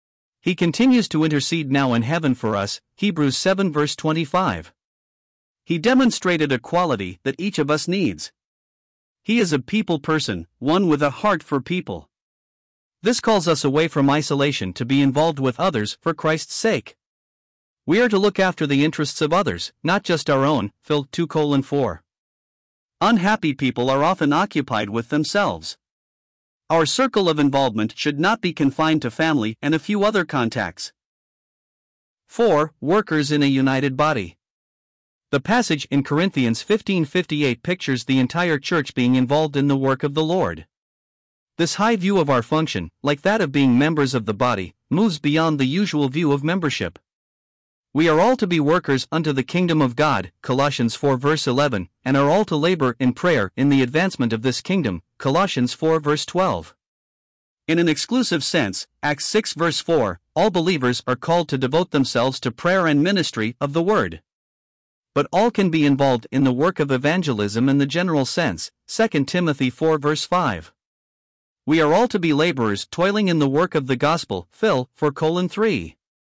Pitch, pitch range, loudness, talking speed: 145 Hz, 125-170 Hz, -20 LUFS, 170 wpm